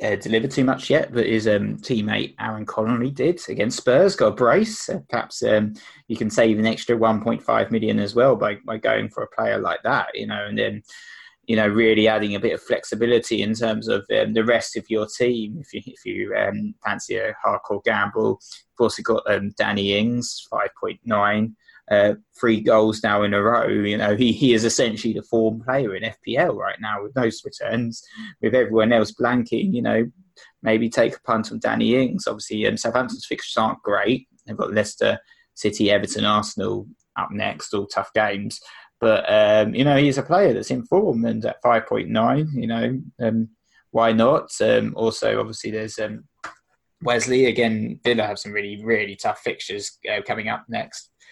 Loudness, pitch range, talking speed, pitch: -21 LUFS, 105-120 Hz, 195 wpm, 115 Hz